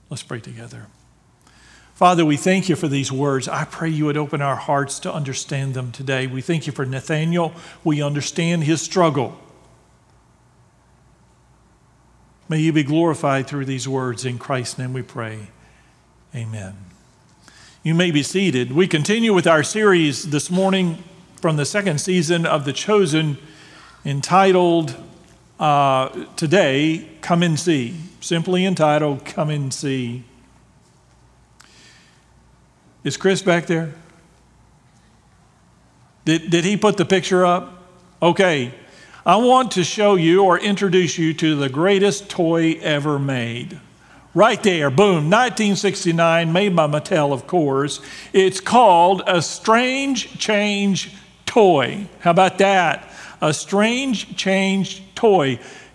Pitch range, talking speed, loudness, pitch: 140-185 Hz, 130 wpm, -18 LUFS, 165 Hz